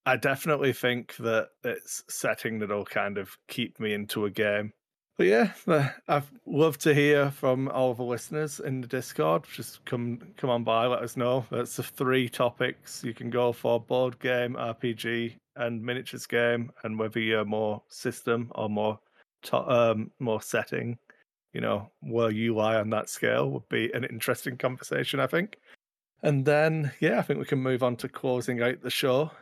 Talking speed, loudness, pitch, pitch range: 185 wpm, -28 LUFS, 120 Hz, 115-130 Hz